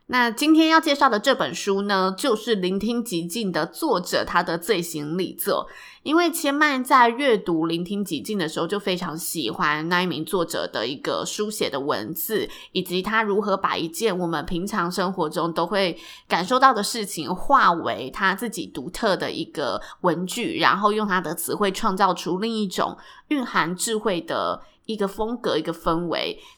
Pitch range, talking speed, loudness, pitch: 175-240 Hz, 270 characters per minute, -23 LUFS, 200 Hz